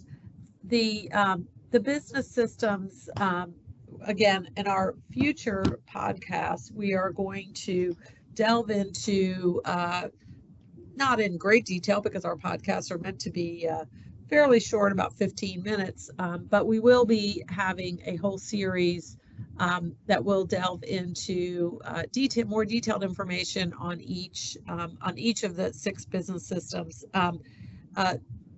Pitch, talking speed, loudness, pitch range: 190 Hz, 140 wpm, -28 LUFS, 175-215 Hz